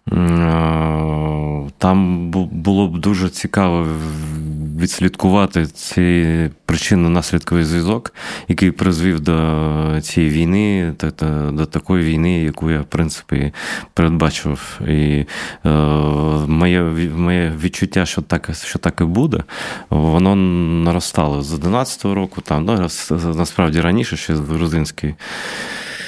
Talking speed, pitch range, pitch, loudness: 95 wpm, 75-90 Hz, 85 Hz, -17 LUFS